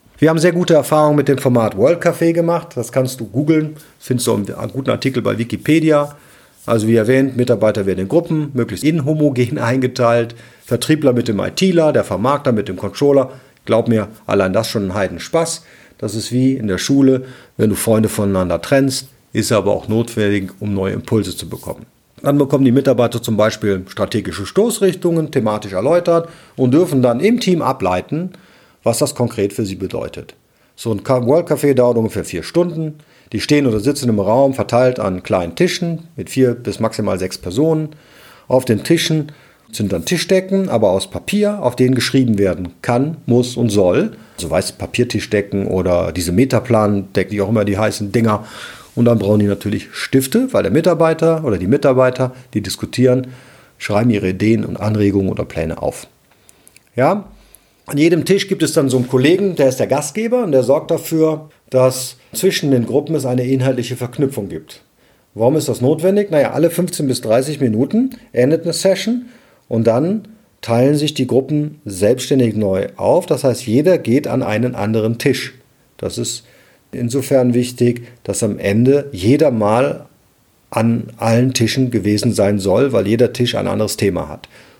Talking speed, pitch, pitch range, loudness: 175 wpm, 125 Hz, 110-150 Hz, -16 LUFS